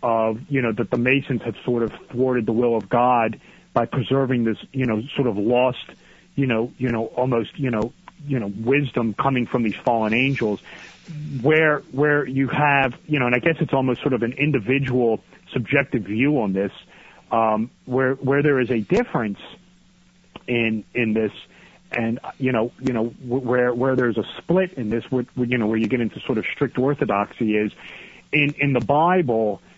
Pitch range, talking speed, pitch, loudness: 115-135 Hz, 185 wpm, 125 Hz, -22 LUFS